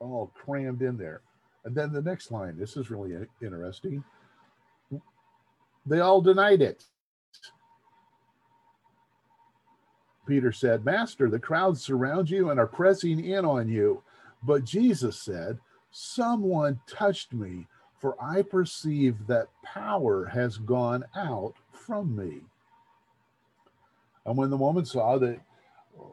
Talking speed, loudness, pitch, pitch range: 120 wpm, -27 LUFS, 140 Hz, 120-190 Hz